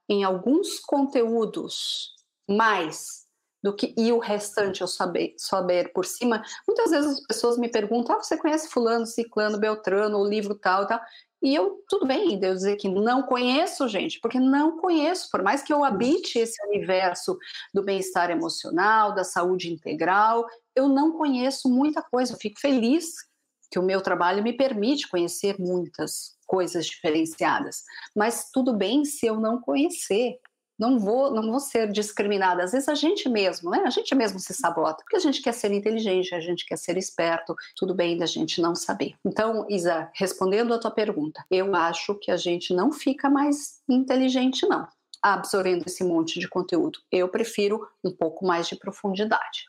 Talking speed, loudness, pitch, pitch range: 175 wpm, -25 LUFS, 220 Hz, 185-270 Hz